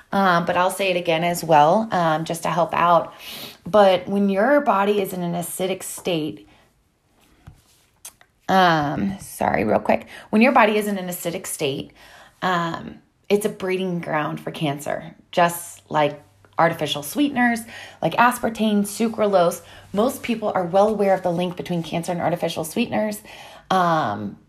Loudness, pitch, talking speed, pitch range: -21 LUFS, 180 Hz, 150 wpm, 165-205 Hz